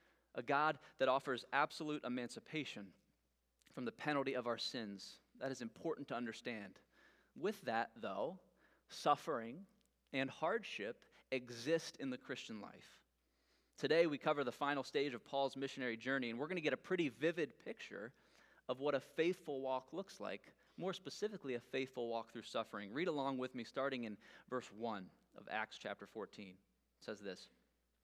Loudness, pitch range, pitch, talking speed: -43 LUFS, 115-145 Hz, 130 Hz, 165 wpm